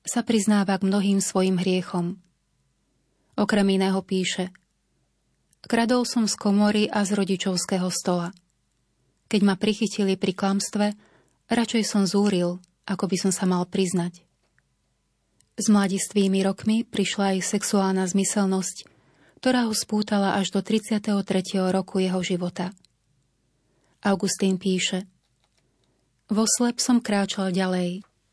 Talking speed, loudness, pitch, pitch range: 115 wpm, -24 LUFS, 195 Hz, 180-205 Hz